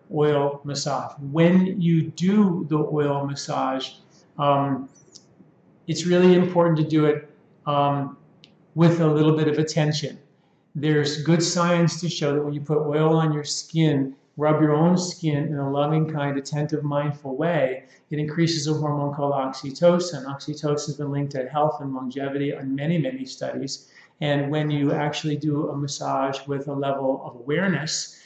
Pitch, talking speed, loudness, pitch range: 150 Hz, 160 wpm, -23 LUFS, 140-160 Hz